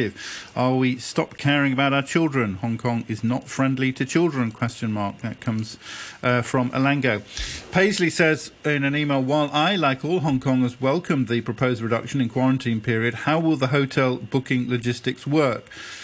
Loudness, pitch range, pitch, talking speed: -22 LUFS, 120-145 Hz, 130 Hz, 170 wpm